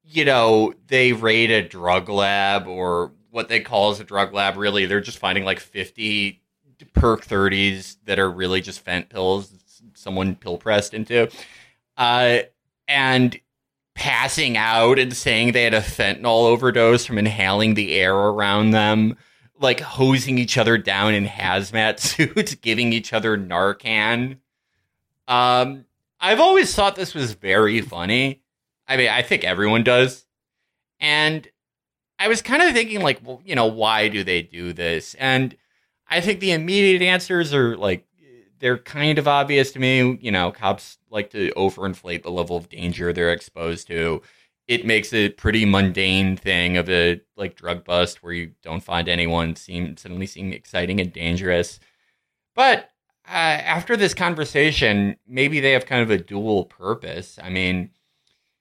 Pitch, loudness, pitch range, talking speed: 110 Hz, -19 LUFS, 95-130 Hz, 160 wpm